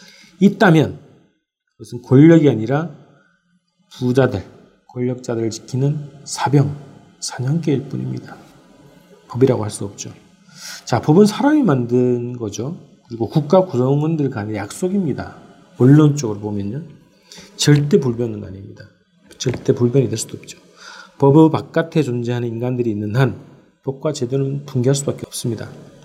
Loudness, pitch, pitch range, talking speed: -17 LUFS, 135 Hz, 120-155 Hz, 290 characters per minute